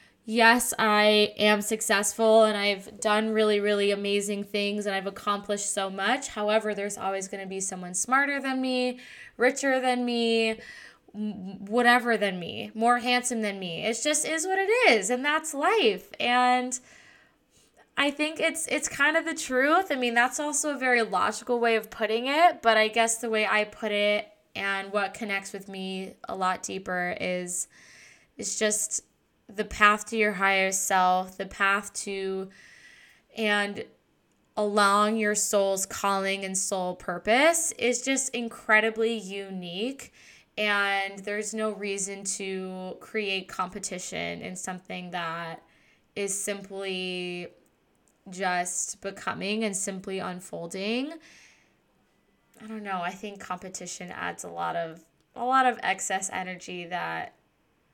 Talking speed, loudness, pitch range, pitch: 145 wpm, -26 LUFS, 195-235 Hz, 210 Hz